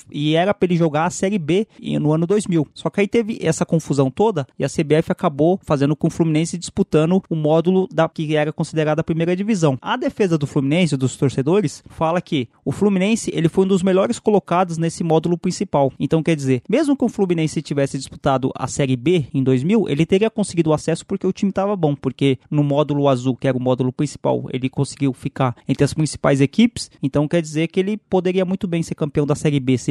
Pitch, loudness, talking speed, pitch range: 160 Hz, -19 LUFS, 220 wpm, 145-185 Hz